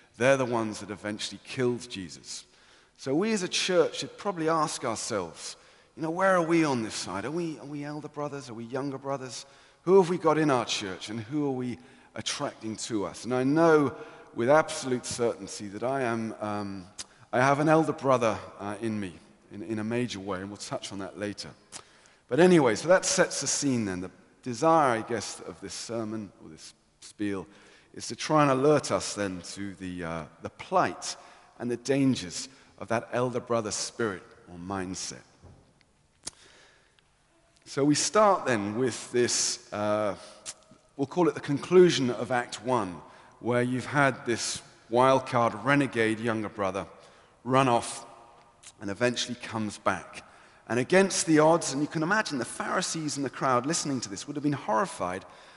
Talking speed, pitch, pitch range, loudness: 180 wpm, 120 Hz, 105-145 Hz, -28 LUFS